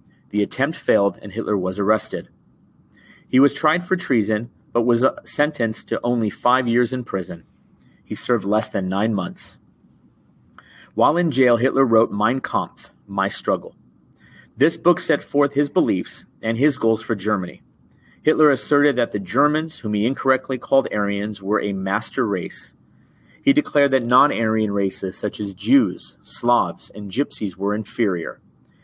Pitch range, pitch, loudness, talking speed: 105-140 Hz, 115 Hz, -21 LUFS, 155 wpm